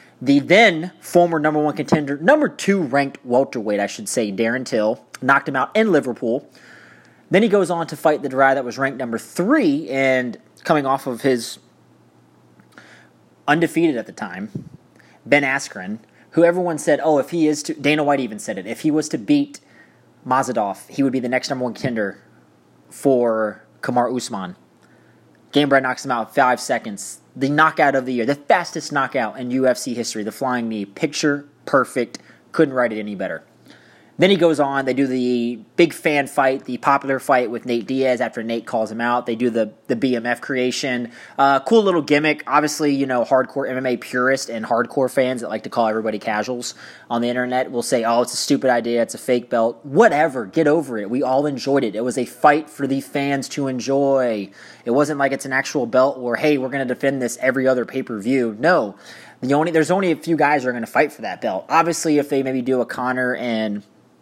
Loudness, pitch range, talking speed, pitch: -19 LUFS, 120-150 Hz, 205 wpm, 135 Hz